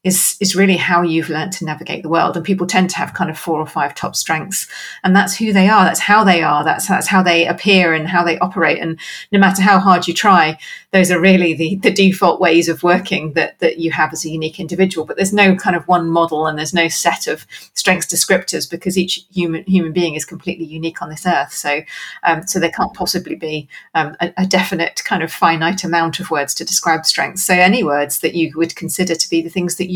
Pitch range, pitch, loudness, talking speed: 165-185 Hz, 175 Hz, -15 LUFS, 240 wpm